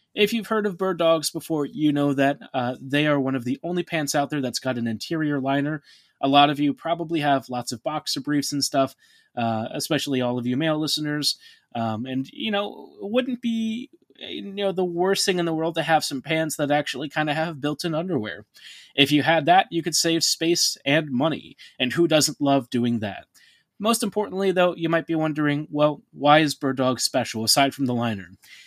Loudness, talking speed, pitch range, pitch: -23 LUFS, 215 wpm, 135-165 Hz, 150 Hz